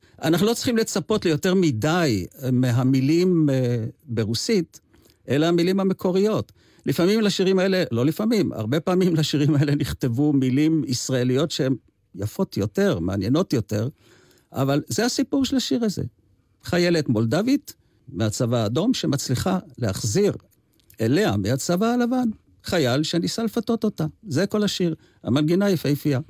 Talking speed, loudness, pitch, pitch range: 120 wpm, -22 LUFS, 155 Hz, 125-190 Hz